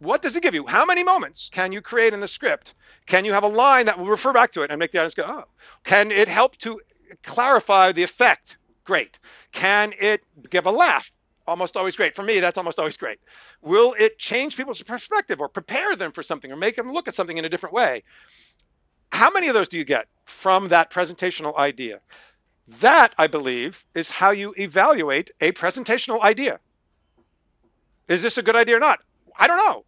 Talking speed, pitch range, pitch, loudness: 210 wpm, 180-245 Hz, 205 Hz, -20 LUFS